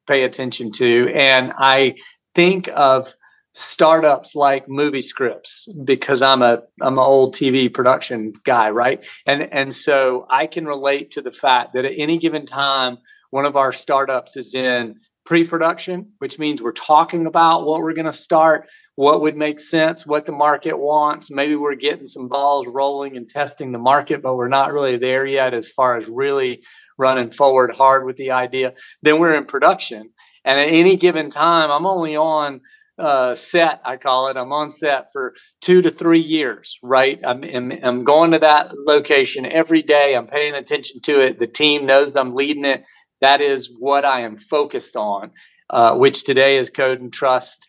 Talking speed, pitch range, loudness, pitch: 185 wpm, 130-160 Hz, -17 LUFS, 140 Hz